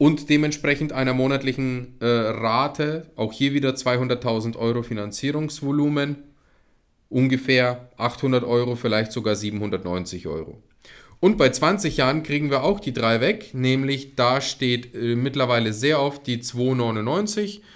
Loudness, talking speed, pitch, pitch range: -22 LUFS, 130 wpm, 130 Hz, 120-145 Hz